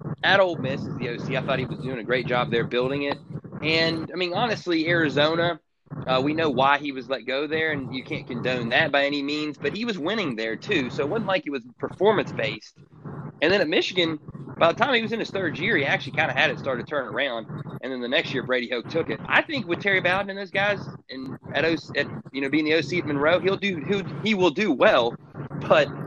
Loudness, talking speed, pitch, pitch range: -24 LUFS, 255 wpm, 155 Hz, 135-175 Hz